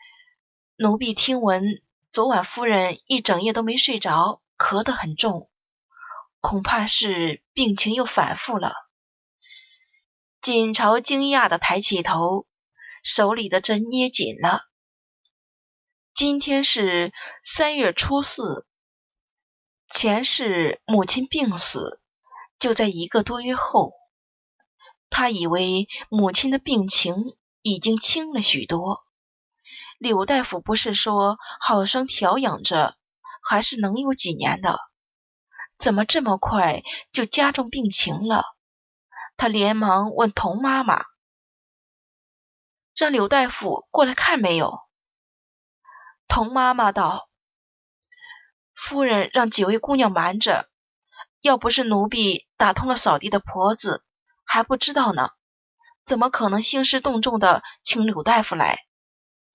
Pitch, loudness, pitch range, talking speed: 225 Hz, -21 LUFS, 200-265 Hz, 170 characters per minute